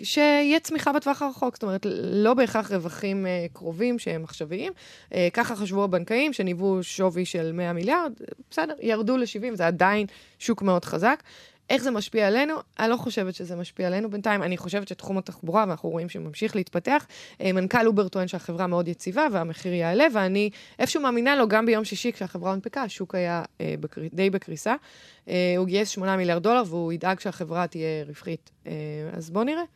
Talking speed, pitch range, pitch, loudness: 160 wpm, 180-235 Hz, 195 Hz, -26 LUFS